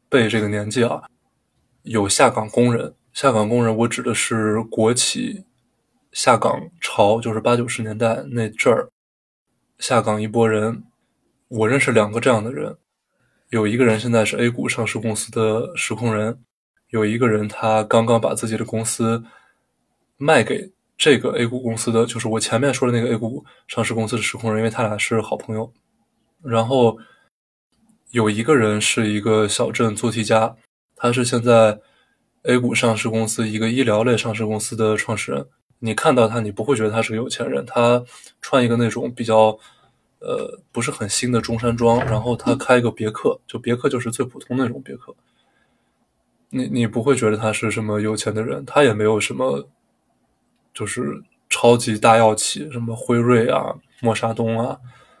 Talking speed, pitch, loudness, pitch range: 260 characters per minute, 115 Hz, -19 LUFS, 110-120 Hz